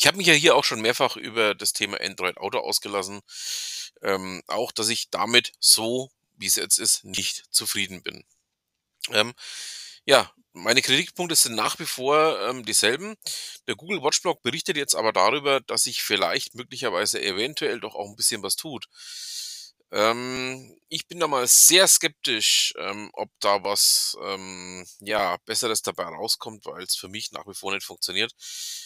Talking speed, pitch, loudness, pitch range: 170 wpm, 130 Hz, -22 LUFS, 100-160 Hz